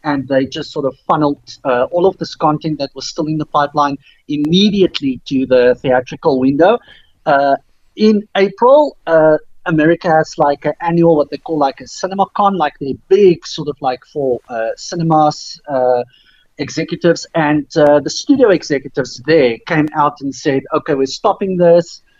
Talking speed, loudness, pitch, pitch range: 170 wpm, -14 LUFS, 150 Hz, 140-170 Hz